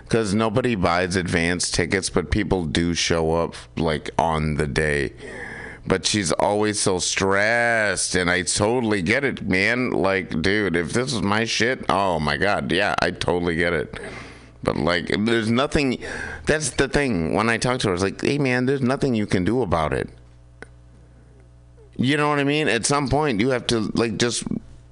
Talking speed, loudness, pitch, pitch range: 185 wpm, -21 LUFS, 95 Hz, 80-120 Hz